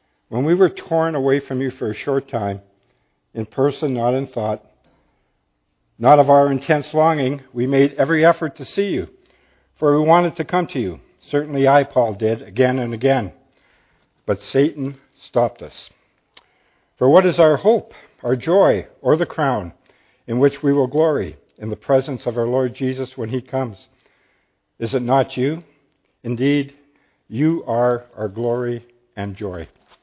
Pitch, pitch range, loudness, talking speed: 135 Hz, 120-145 Hz, -19 LUFS, 165 wpm